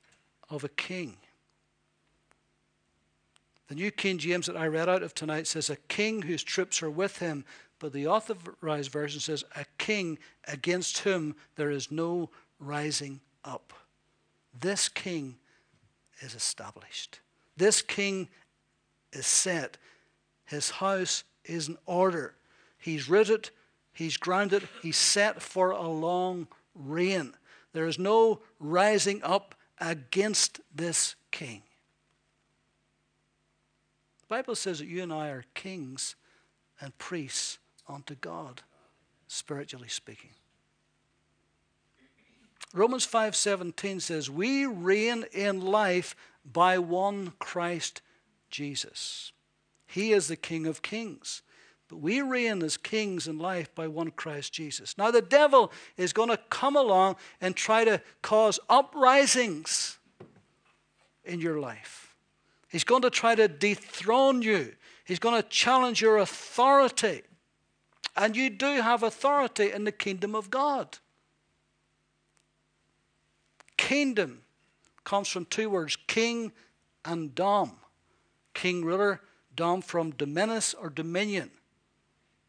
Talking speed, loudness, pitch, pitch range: 120 wpm, -28 LUFS, 185 Hz, 155-215 Hz